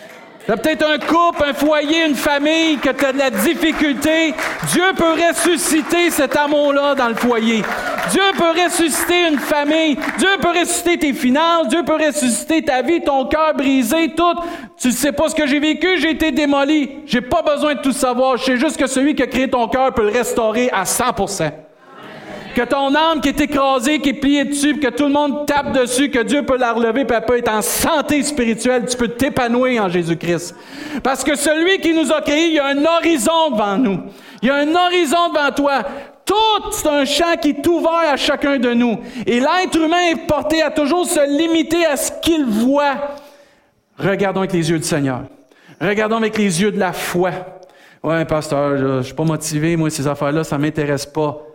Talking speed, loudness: 205 wpm, -16 LUFS